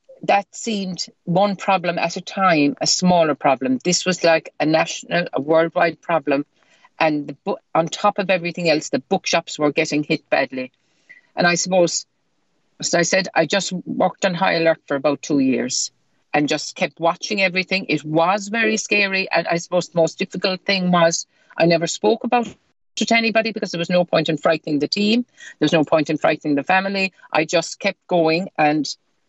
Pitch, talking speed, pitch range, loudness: 170 Hz, 195 wpm, 155-195 Hz, -19 LUFS